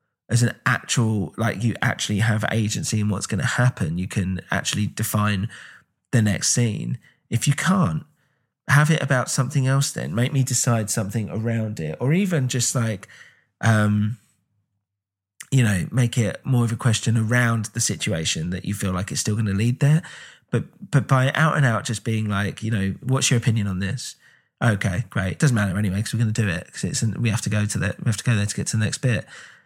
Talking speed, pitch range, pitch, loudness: 215 wpm, 105-130 Hz, 115 Hz, -22 LUFS